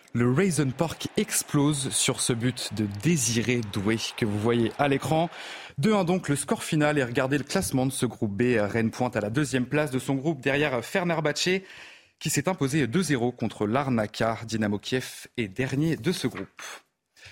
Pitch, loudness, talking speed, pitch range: 135 Hz, -26 LUFS, 185 wpm, 120-155 Hz